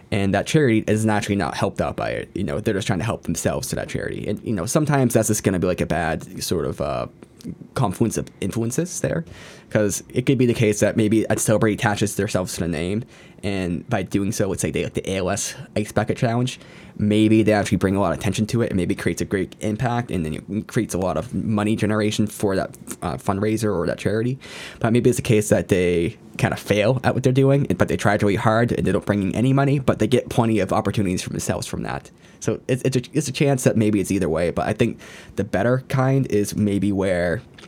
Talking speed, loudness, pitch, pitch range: 255 wpm, -21 LUFS, 105 Hz, 100-120 Hz